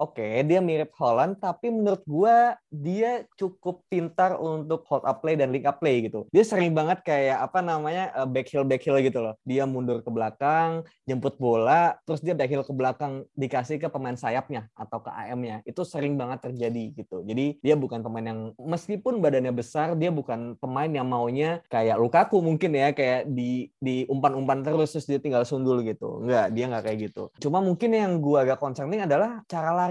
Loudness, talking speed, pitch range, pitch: -26 LUFS, 195 wpm, 125-170 Hz, 145 Hz